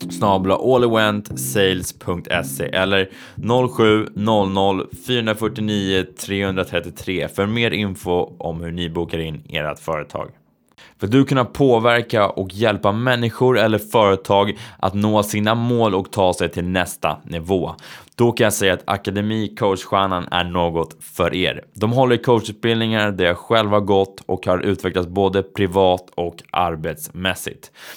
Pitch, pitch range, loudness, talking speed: 100 Hz, 90-110 Hz, -19 LUFS, 130 wpm